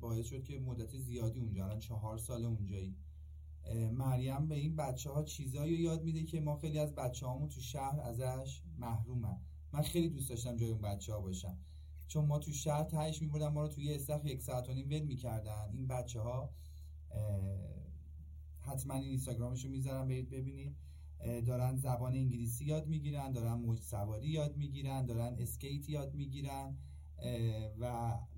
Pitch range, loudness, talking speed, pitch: 100-140 Hz, -40 LUFS, 165 wpm, 125 Hz